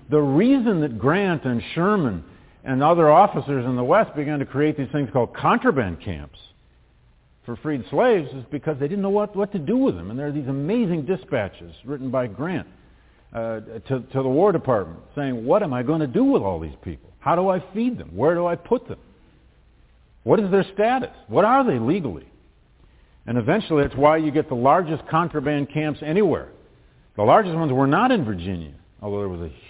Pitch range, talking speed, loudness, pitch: 110-170 Hz, 205 wpm, -21 LUFS, 140 Hz